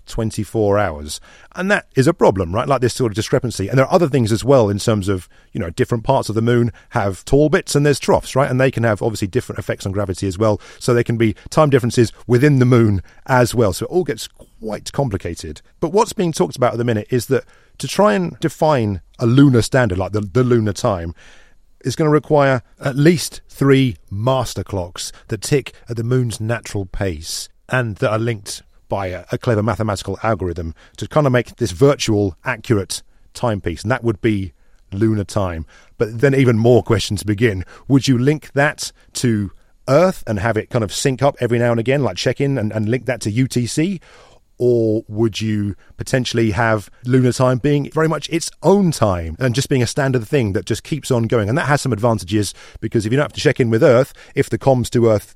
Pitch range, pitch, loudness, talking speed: 105-135 Hz, 120 Hz, -18 LUFS, 220 wpm